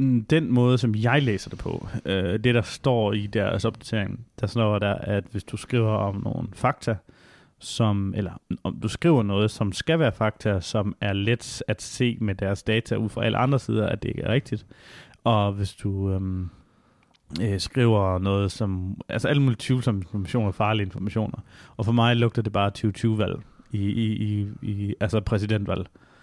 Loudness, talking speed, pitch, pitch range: -25 LUFS, 180 wpm, 110 Hz, 100-120 Hz